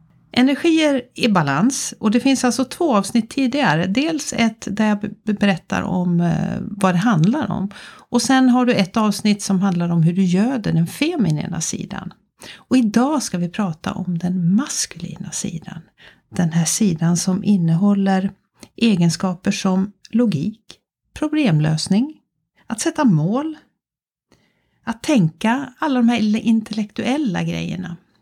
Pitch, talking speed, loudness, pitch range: 205 Hz, 135 wpm, -19 LUFS, 180-240 Hz